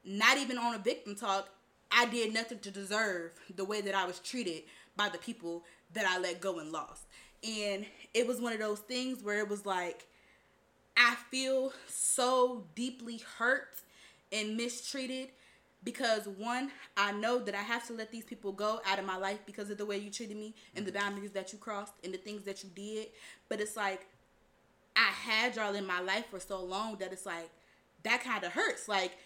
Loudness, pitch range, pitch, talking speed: -34 LUFS, 195-235 Hz, 210 Hz, 205 wpm